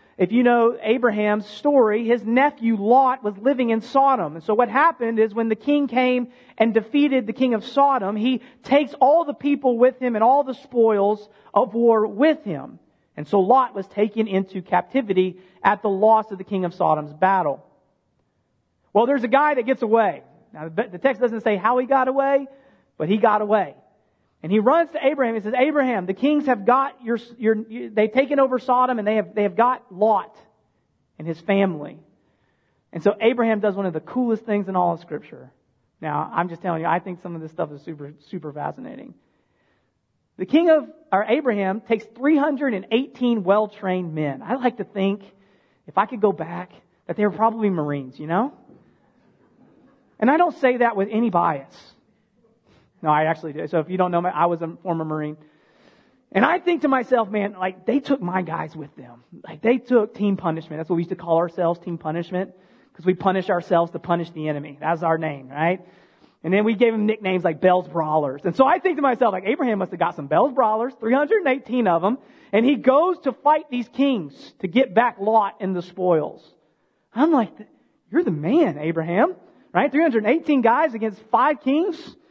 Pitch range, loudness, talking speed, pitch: 180-255 Hz, -21 LUFS, 200 wpm, 215 Hz